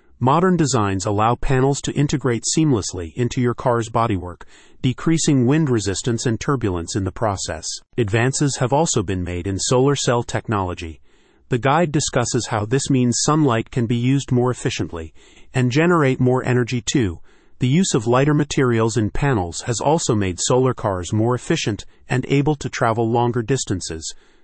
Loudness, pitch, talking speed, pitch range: -19 LUFS, 125 Hz, 160 wpm, 110-135 Hz